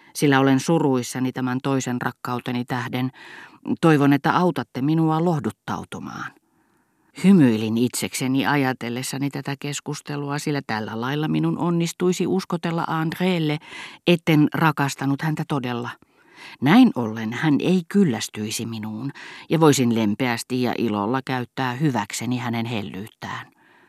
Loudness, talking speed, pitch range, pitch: -22 LUFS, 110 wpm, 125-160 Hz, 140 Hz